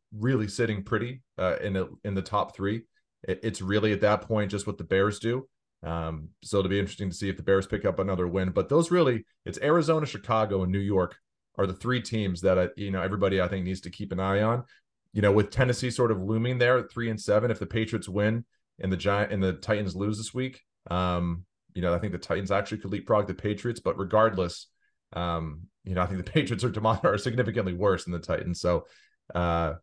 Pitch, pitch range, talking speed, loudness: 100 Hz, 95-110 Hz, 235 wpm, -28 LUFS